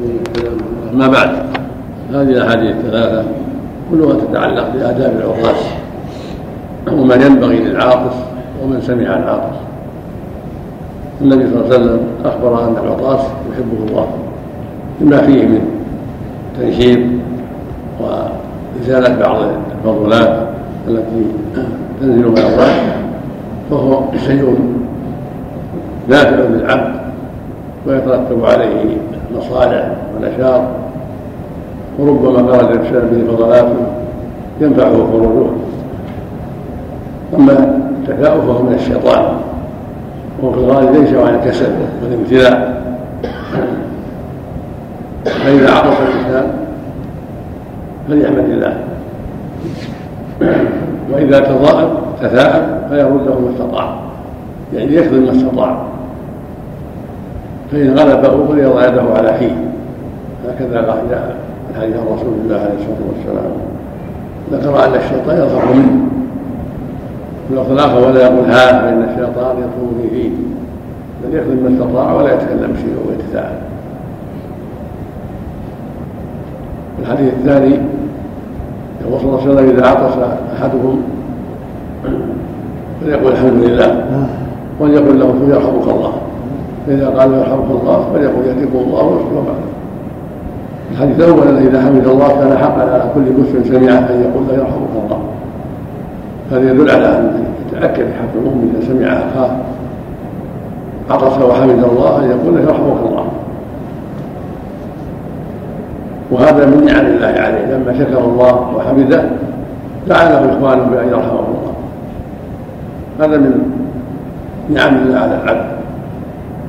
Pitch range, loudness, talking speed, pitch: 125-135 Hz, -12 LUFS, 100 wpm, 130 Hz